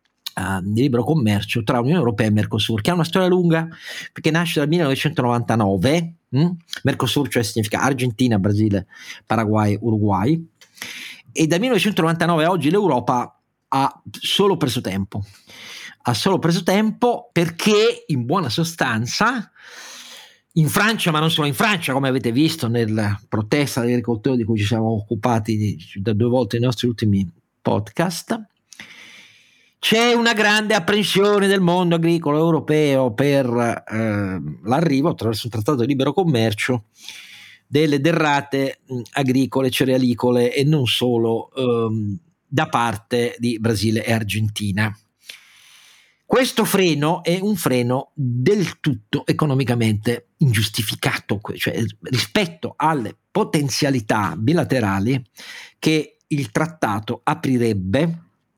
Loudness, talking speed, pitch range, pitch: -19 LUFS, 120 wpm, 115-165 Hz, 130 Hz